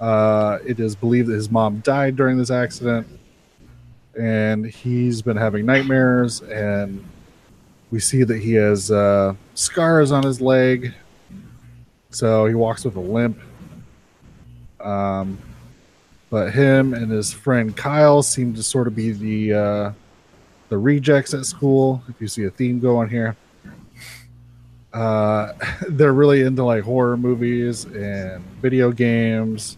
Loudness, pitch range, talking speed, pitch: -19 LUFS, 105-125 Hz, 135 wpm, 115 Hz